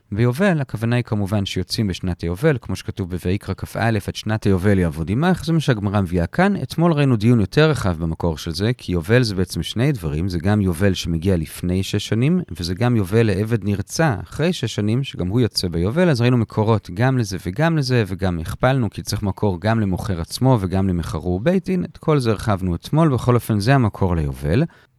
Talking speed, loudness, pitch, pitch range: 200 wpm, -20 LUFS, 105 Hz, 90-125 Hz